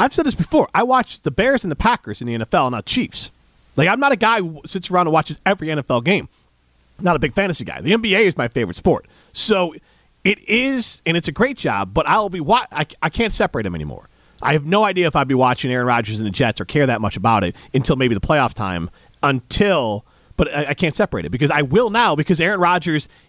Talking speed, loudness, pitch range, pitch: 245 wpm, -18 LUFS, 120-195 Hz, 155 Hz